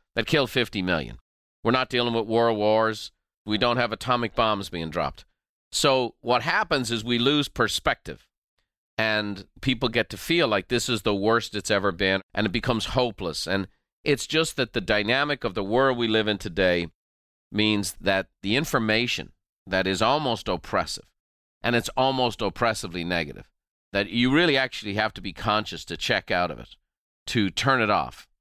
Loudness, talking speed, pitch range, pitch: -25 LUFS, 175 wpm, 95-120 Hz, 110 Hz